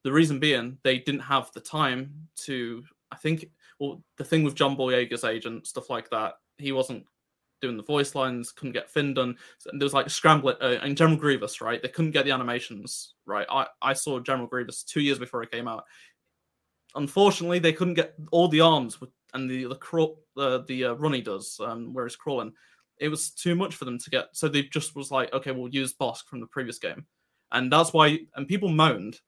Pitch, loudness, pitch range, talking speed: 135 Hz, -26 LUFS, 125-155 Hz, 220 wpm